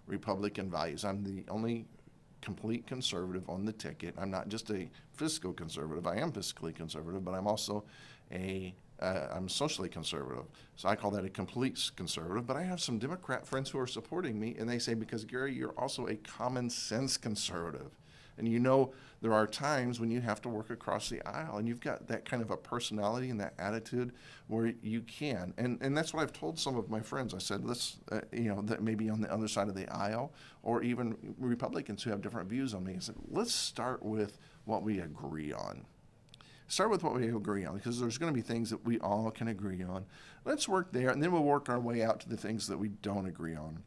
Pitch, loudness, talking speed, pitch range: 115 Hz, -37 LUFS, 225 wpm, 100-125 Hz